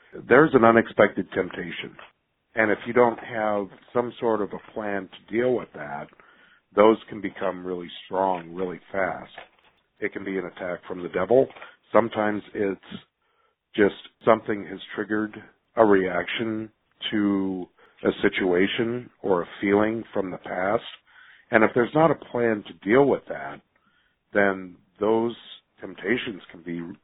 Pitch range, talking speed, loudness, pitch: 95-115 Hz, 145 wpm, -24 LUFS, 105 Hz